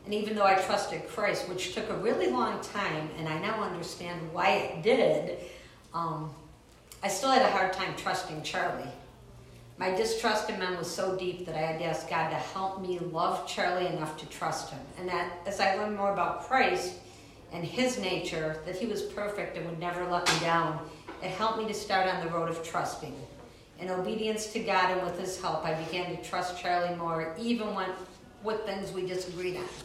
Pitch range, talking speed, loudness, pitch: 165-195 Hz, 205 wpm, -31 LUFS, 180 Hz